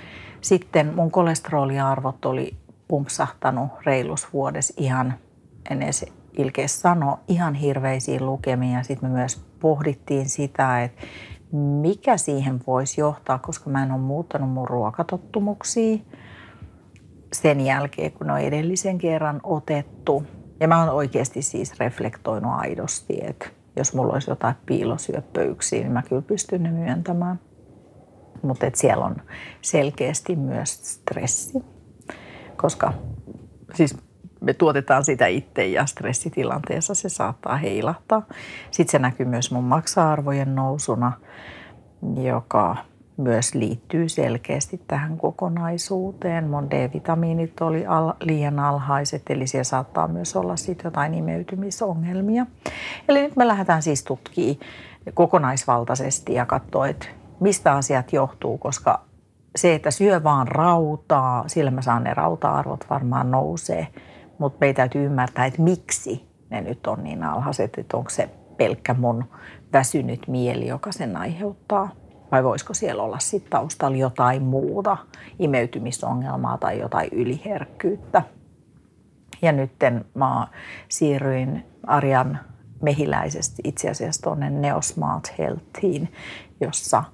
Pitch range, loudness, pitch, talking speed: 125-165 Hz, -23 LUFS, 140 Hz, 120 wpm